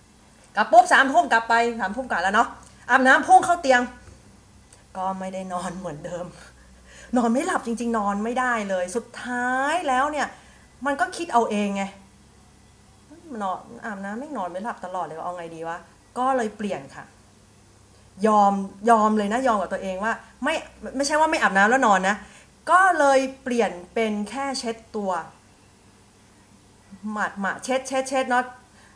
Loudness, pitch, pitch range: -22 LUFS, 215 Hz, 180-255 Hz